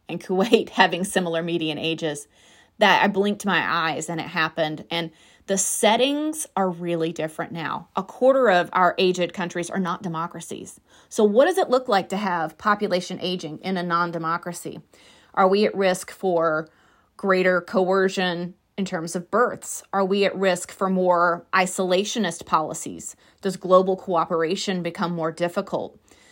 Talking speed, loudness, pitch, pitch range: 155 wpm, -23 LUFS, 185 Hz, 170-195 Hz